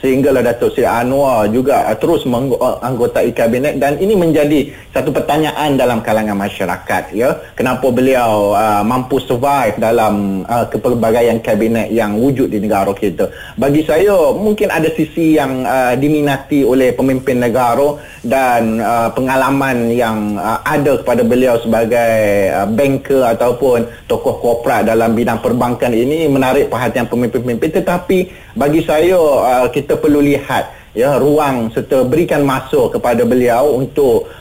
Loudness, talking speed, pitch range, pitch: -13 LUFS, 135 wpm, 115-145 Hz, 125 Hz